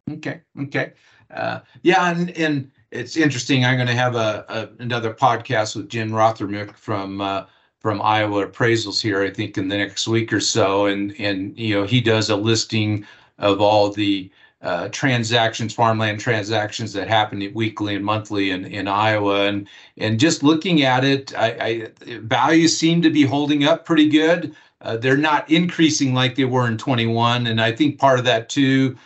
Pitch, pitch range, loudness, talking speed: 115 Hz, 105-135 Hz, -19 LUFS, 180 wpm